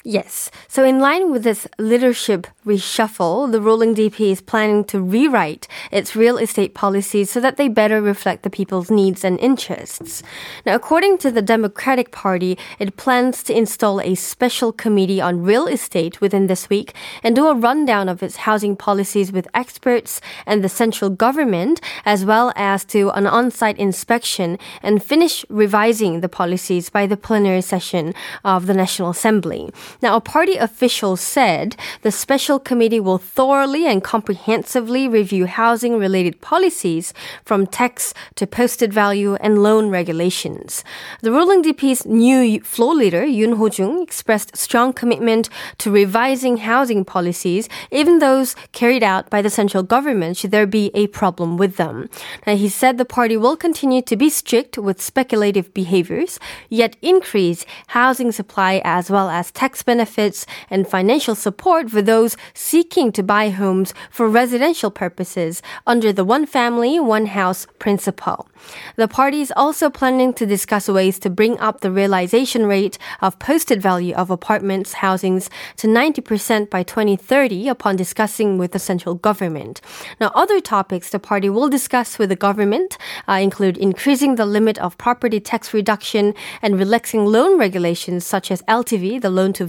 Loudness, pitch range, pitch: -17 LUFS, 195-245 Hz, 215 Hz